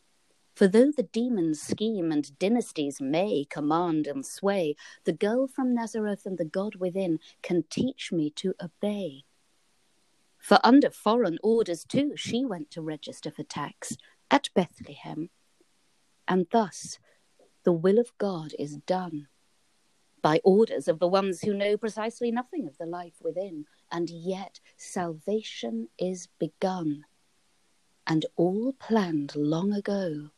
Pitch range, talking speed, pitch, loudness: 160-220 Hz, 135 wpm, 185 Hz, -28 LUFS